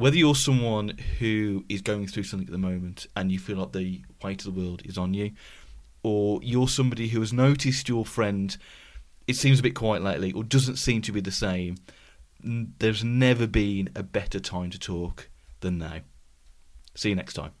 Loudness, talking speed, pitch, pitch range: -27 LUFS, 200 wpm, 100 Hz, 90-115 Hz